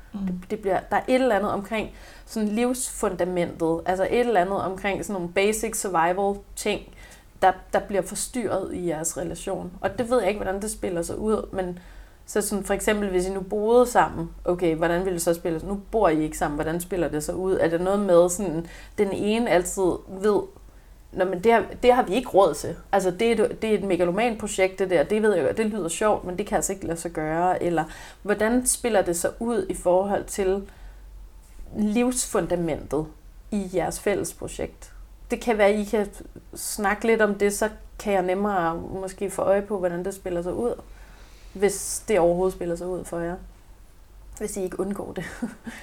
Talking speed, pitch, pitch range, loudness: 205 wpm, 190 Hz, 175-210 Hz, -24 LUFS